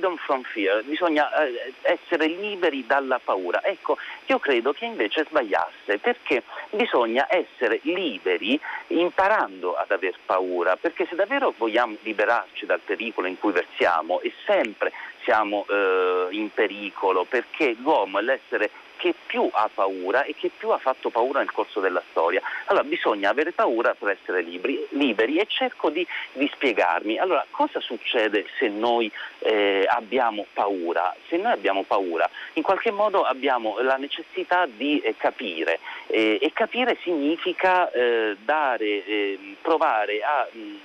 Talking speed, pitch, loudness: 145 wpm, 160 Hz, -24 LUFS